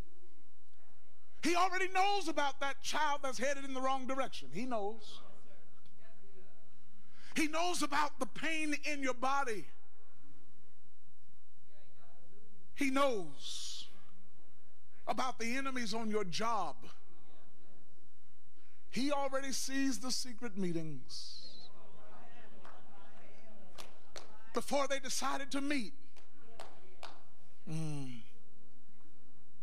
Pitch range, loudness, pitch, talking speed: 195-280 Hz, -37 LUFS, 255 Hz, 85 wpm